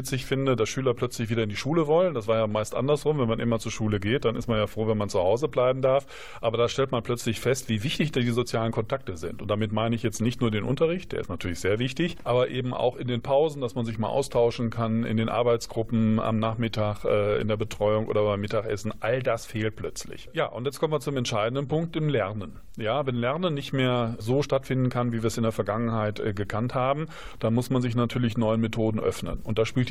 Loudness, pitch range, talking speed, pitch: -27 LUFS, 110-130 Hz, 245 wpm, 120 Hz